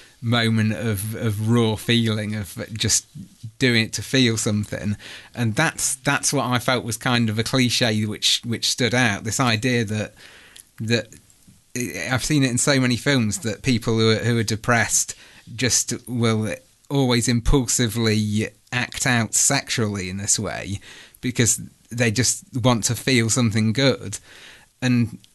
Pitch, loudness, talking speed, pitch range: 115 Hz, -21 LUFS, 150 wpm, 110-125 Hz